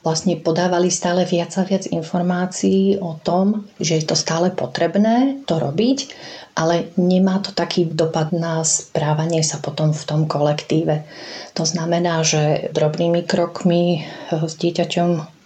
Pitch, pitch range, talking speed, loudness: 170 Hz, 160-180 Hz, 135 wpm, -19 LUFS